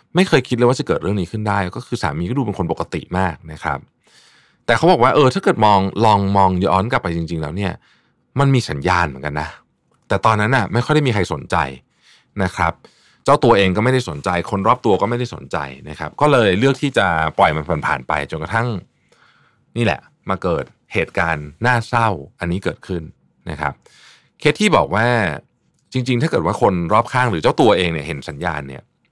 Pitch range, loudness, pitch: 85-120 Hz, -18 LUFS, 100 Hz